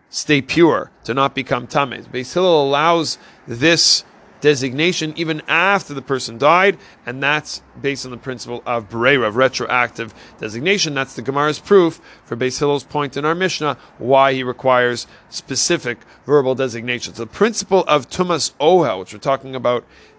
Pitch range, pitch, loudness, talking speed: 125-160 Hz, 135 Hz, -17 LUFS, 150 wpm